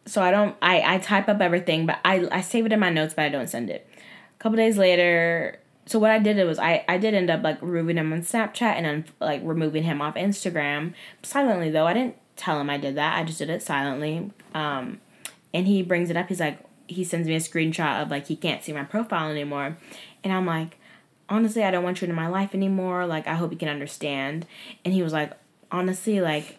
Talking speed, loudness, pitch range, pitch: 240 wpm, -24 LUFS, 155-195 Hz, 170 Hz